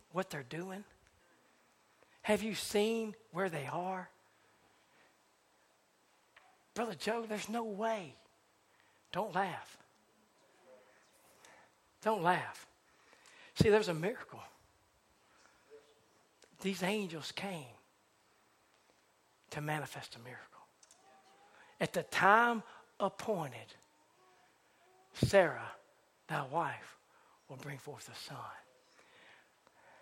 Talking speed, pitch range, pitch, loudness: 80 wpm, 155-220 Hz, 195 Hz, -36 LUFS